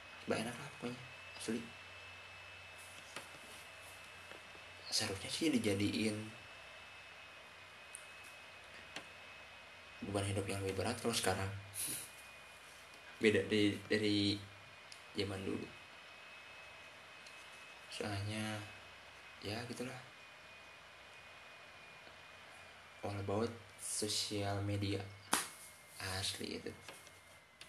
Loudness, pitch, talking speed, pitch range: -40 LUFS, 100 Hz, 65 wpm, 95-110 Hz